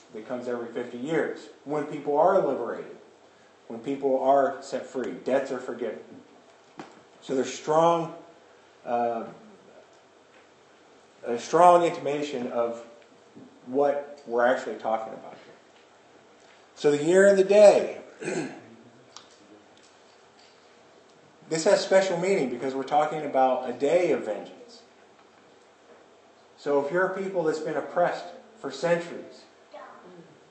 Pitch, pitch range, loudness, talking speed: 145 Hz, 125-170 Hz, -25 LUFS, 115 wpm